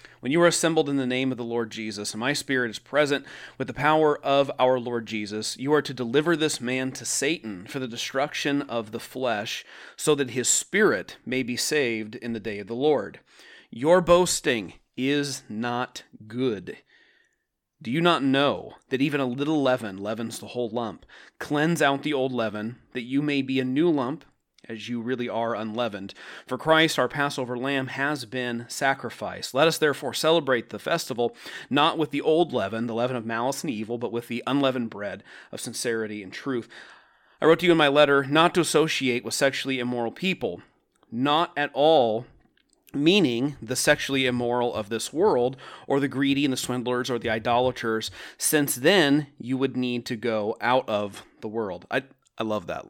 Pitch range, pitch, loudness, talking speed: 115-145 Hz, 130 Hz, -25 LUFS, 190 wpm